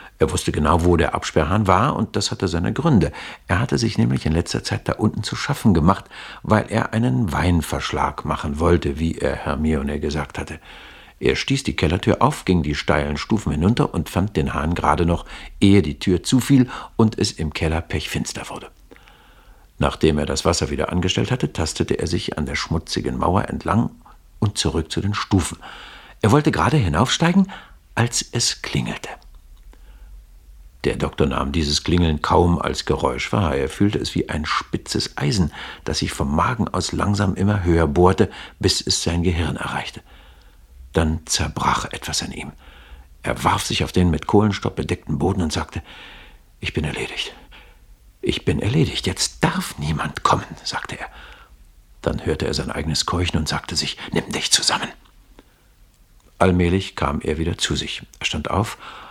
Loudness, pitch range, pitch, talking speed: -21 LUFS, 75-100 Hz, 85 Hz, 170 wpm